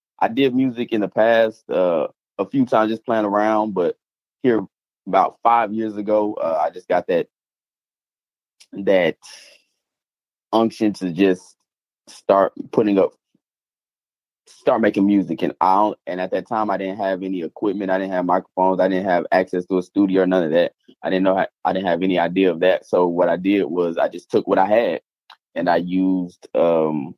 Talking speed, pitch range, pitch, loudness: 190 wpm, 90-110 Hz, 95 Hz, -20 LUFS